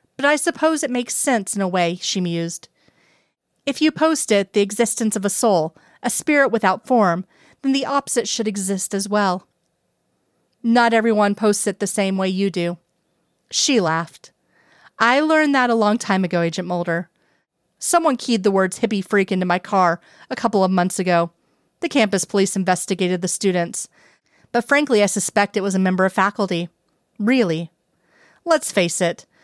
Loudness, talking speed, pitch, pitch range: -19 LUFS, 175 wpm, 200 Hz, 185-235 Hz